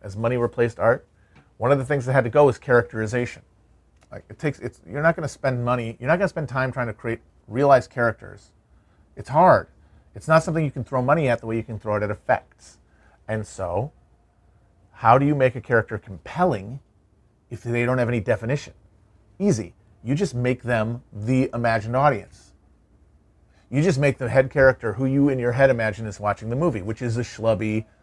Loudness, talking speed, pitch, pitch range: -22 LUFS, 205 wpm, 120 Hz, 105-130 Hz